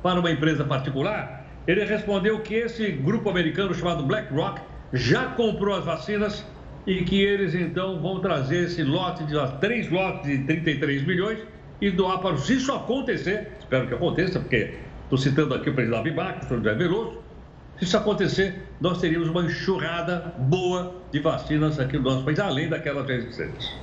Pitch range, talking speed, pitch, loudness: 150-195 Hz, 170 wpm, 175 Hz, -25 LUFS